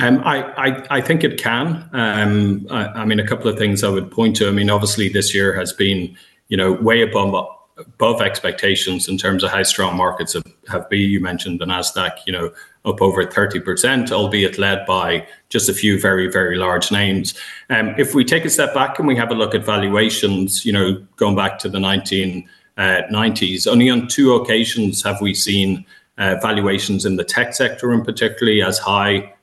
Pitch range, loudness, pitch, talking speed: 95-110 Hz, -17 LUFS, 100 Hz, 200 wpm